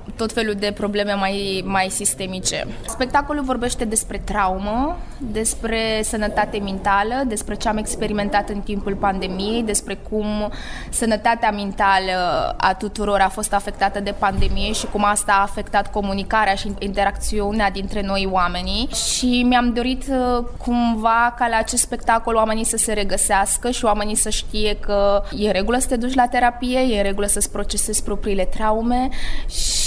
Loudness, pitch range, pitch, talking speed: -20 LUFS, 200-230 Hz, 210 Hz, 150 wpm